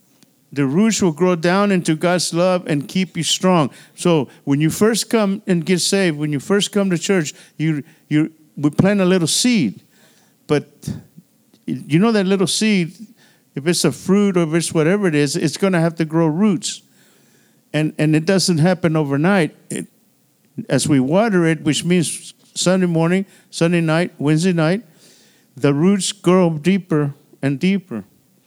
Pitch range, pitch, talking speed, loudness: 155-190 Hz, 175 Hz, 170 wpm, -17 LUFS